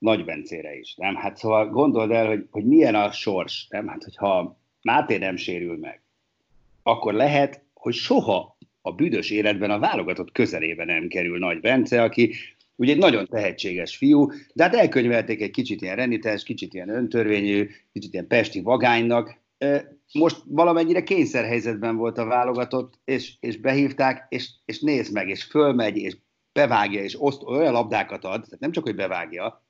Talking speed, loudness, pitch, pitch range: 165 wpm, -23 LUFS, 120 Hz, 110-140 Hz